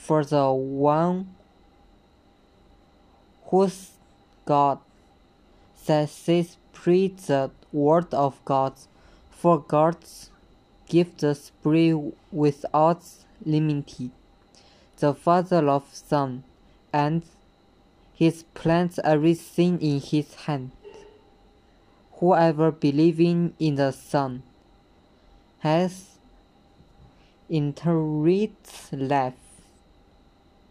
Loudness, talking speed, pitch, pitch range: -24 LUFS, 70 wpm, 155 Hz, 140-170 Hz